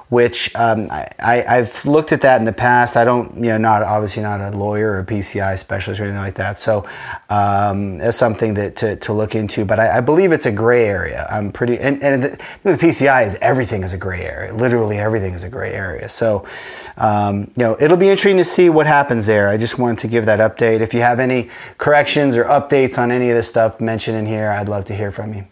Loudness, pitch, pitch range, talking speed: -16 LUFS, 115 Hz, 105-125 Hz, 245 wpm